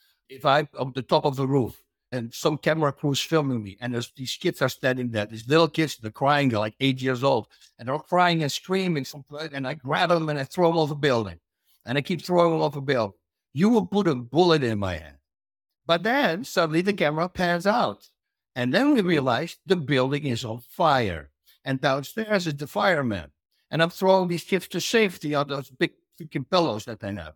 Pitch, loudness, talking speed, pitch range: 150 Hz, -24 LUFS, 220 wpm, 125-175 Hz